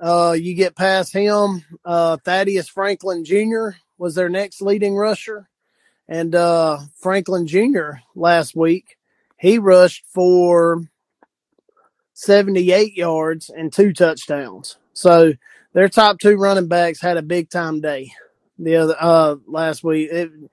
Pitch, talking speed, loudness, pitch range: 175 Hz, 130 wpm, -16 LUFS, 165-195 Hz